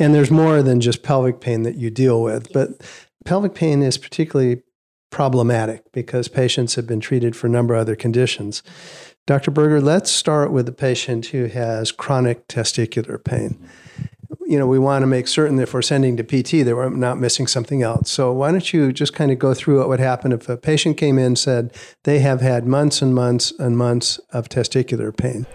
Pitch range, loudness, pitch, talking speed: 120-140 Hz, -18 LUFS, 130 Hz, 210 wpm